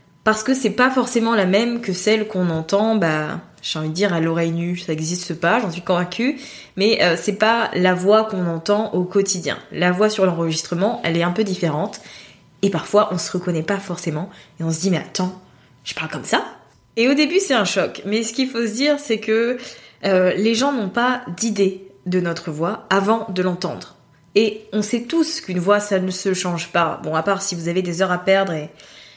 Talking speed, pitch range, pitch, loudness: 225 wpm, 175-220 Hz, 190 Hz, -20 LUFS